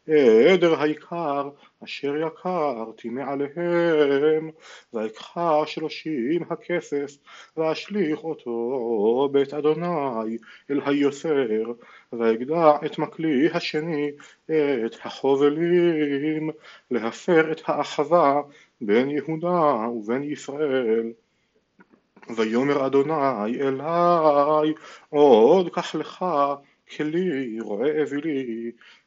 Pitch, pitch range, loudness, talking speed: 150 Hz, 140-160 Hz, -23 LUFS, 75 wpm